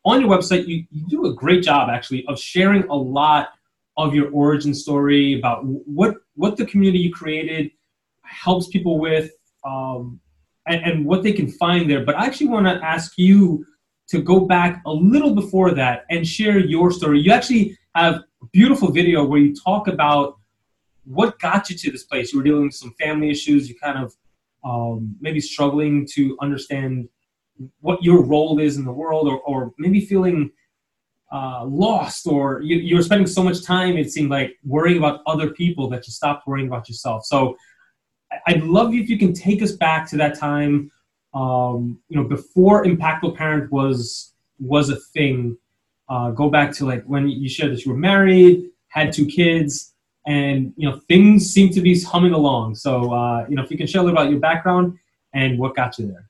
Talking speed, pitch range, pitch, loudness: 195 wpm, 135-180 Hz, 150 Hz, -18 LUFS